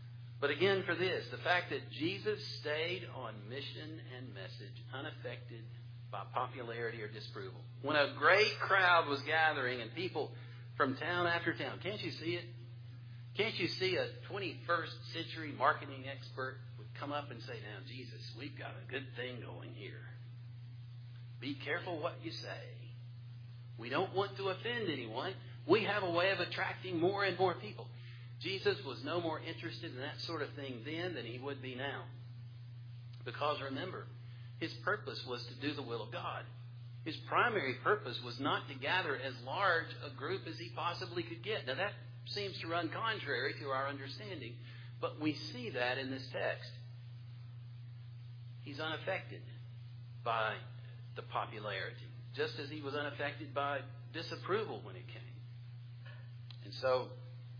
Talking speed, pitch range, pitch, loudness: 160 wpm, 120-140 Hz, 120 Hz, -38 LUFS